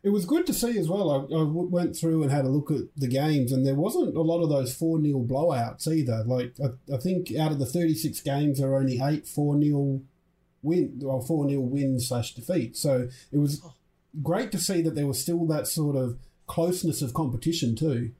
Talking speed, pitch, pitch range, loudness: 220 wpm, 145 Hz, 135-165 Hz, -27 LUFS